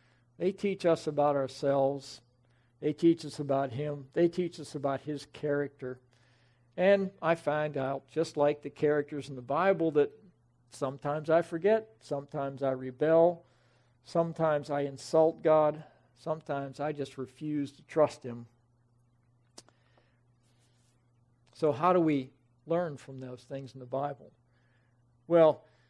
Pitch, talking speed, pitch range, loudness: 140 Hz, 130 wpm, 120-155 Hz, -30 LUFS